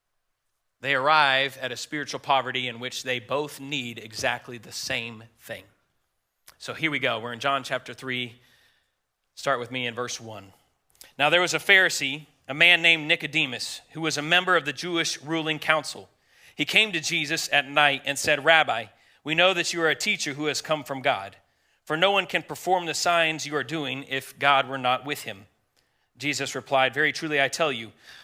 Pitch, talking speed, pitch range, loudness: 145 Hz, 195 wpm, 125-160 Hz, -24 LUFS